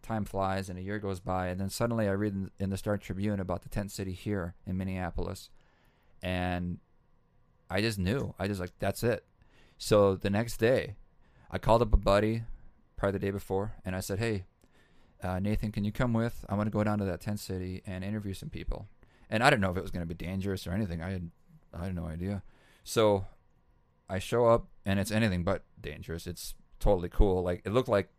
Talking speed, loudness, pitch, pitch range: 215 wpm, -32 LUFS, 100 Hz, 90-105 Hz